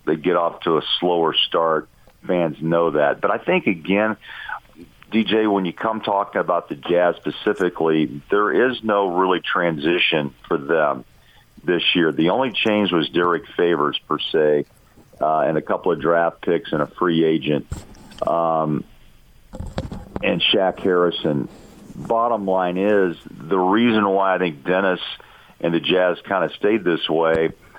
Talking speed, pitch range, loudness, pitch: 155 wpm, 80-100 Hz, -20 LUFS, 90 Hz